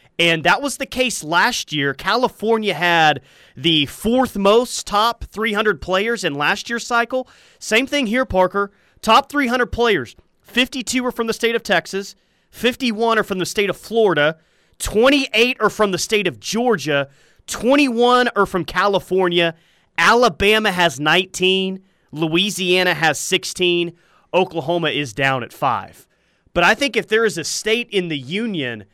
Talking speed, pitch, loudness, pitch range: 150 wpm, 200 Hz, -18 LUFS, 170-235 Hz